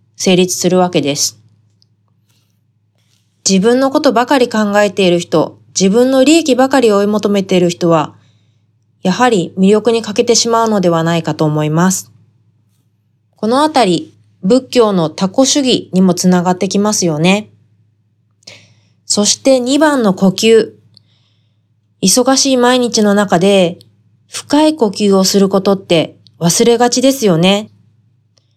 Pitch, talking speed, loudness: 180 Hz, 250 characters per minute, -11 LUFS